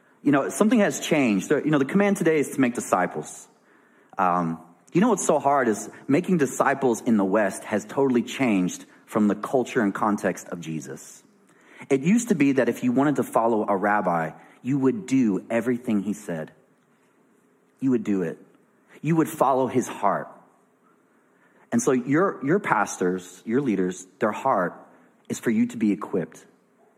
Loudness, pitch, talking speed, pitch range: -24 LUFS, 120 Hz, 175 wpm, 95-140 Hz